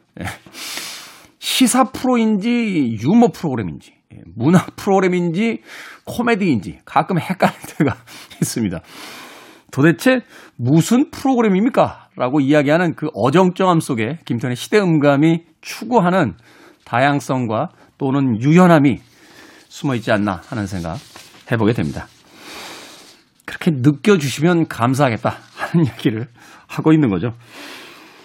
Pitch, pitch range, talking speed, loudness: 160 Hz, 140-190 Hz, 270 characters per minute, -17 LUFS